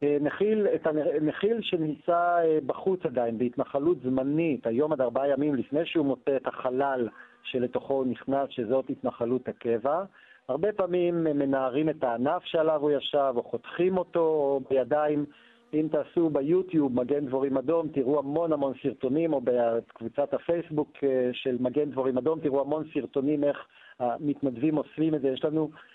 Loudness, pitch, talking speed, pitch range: -28 LUFS, 145 Hz, 145 wpm, 130-160 Hz